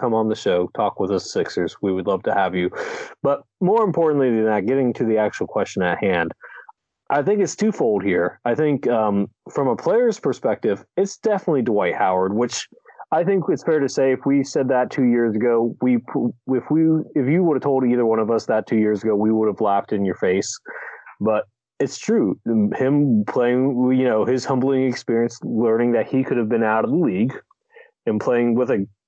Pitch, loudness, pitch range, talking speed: 125 Hz, -20 LUFS, 110-140 Hz, 215 wpm